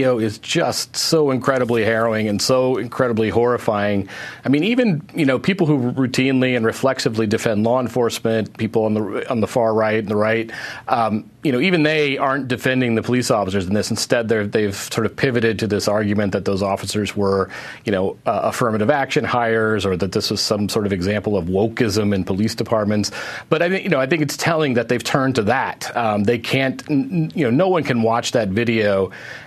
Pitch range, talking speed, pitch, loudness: 105-130 Hz, 205 wpm, 115 Hz, -19 LUFS